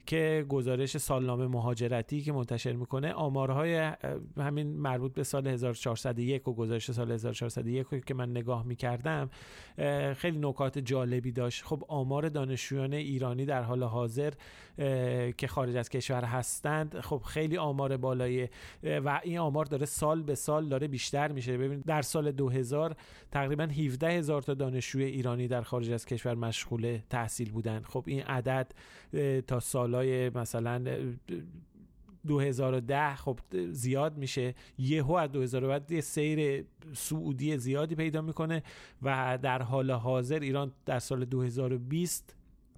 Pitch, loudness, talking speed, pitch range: 135 Hz, -33 LUFS, 135 wpm, 125-150 Hz